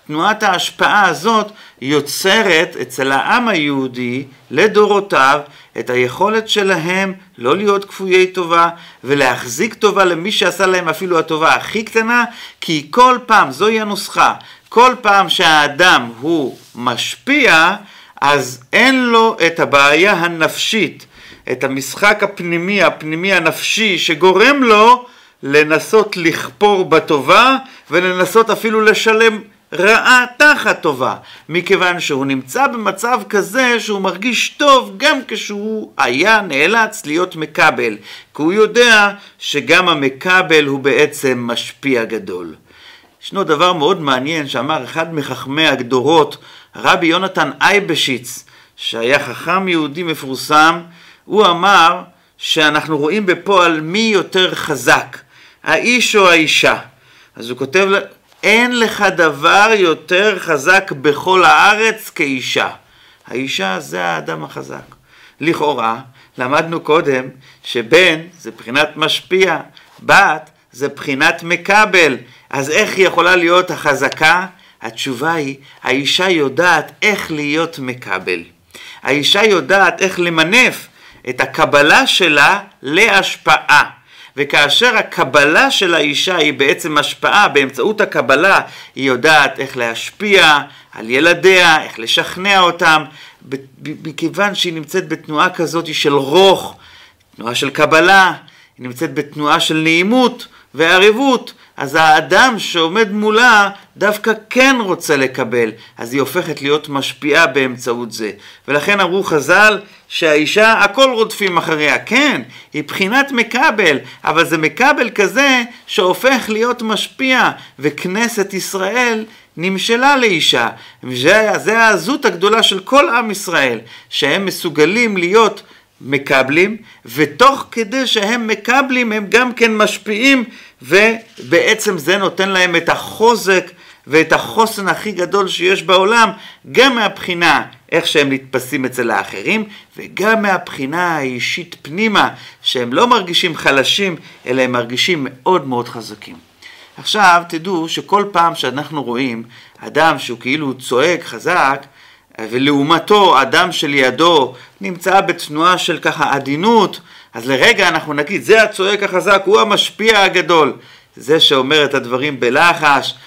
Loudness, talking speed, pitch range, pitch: -12 LUFS, 115 wpm, 150-210 Hz, 180 Hz